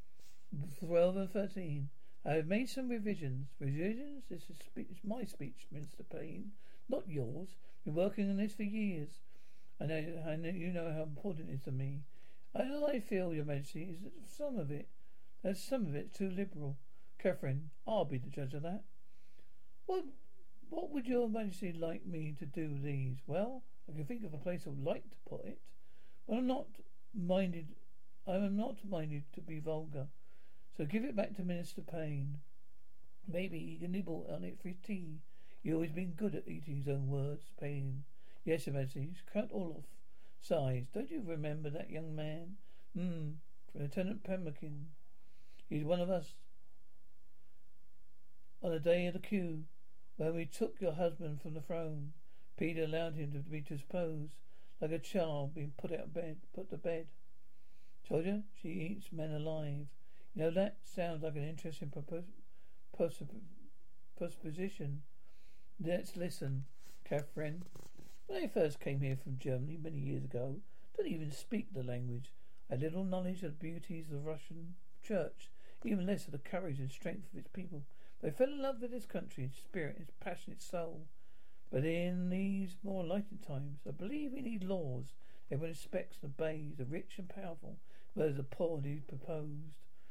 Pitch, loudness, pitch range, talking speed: 165 Hz, -41 LUFS, 145-190 Hz, 175 wpm